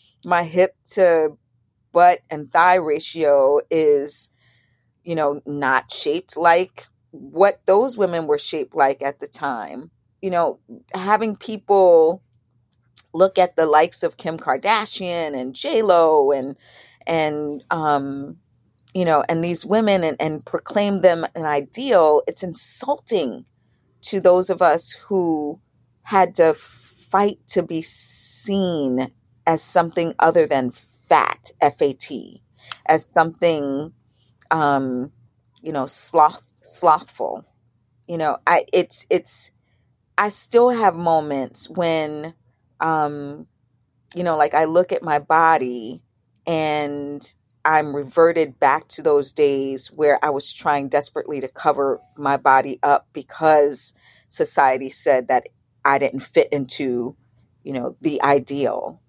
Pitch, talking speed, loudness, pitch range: 150 Hz, 125 wpm, -19 LUFS, 130-170 Hz